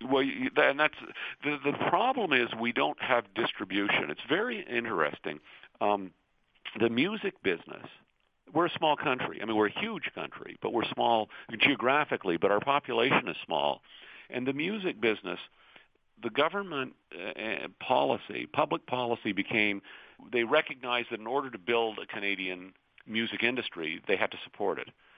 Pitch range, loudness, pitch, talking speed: 110-145 Hz, -30 LUFS, 120 Hz, 155 wpm